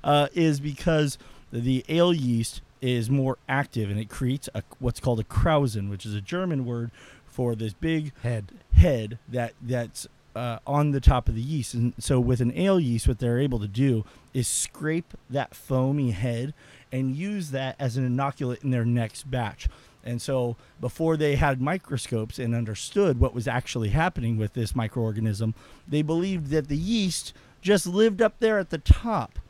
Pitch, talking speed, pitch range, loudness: 130 Hz, 185 wpm, 120-145 Hz, -26 LUFS